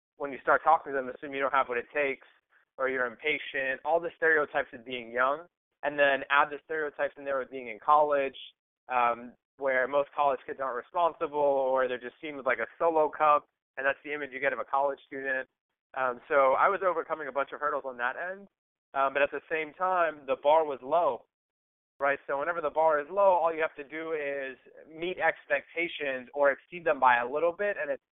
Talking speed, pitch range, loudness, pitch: 225 wpm, 135-160 Hz, -29 LUFS, 145 Hz